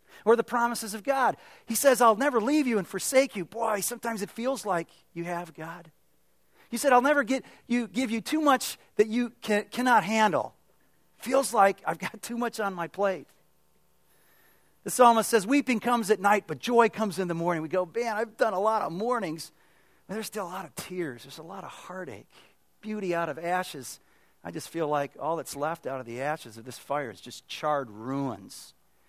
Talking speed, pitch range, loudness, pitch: 210 wpm, 170-235 Hz, -27 LUFS, 205 Hz